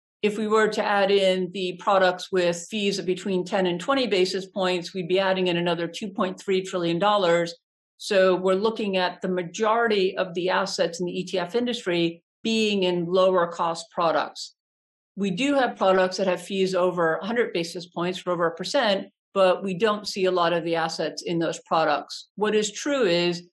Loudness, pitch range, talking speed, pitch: -24 LUFS, 175-205 Hz, 185 wpm, 185 Hz